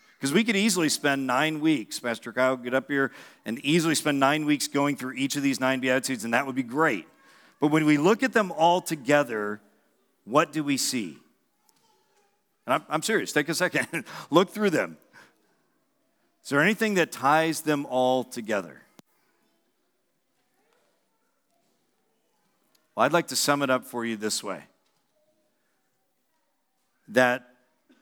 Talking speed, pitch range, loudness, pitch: 150 wpm, 130-170 Hz, -25 LUFS, 145 Hz